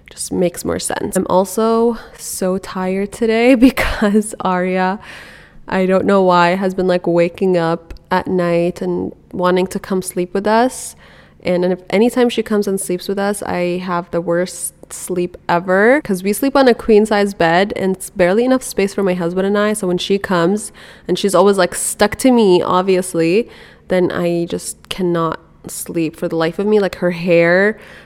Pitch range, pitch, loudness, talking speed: 180-205 Hz, 185 Hz, -16 LUFS, 185 wpm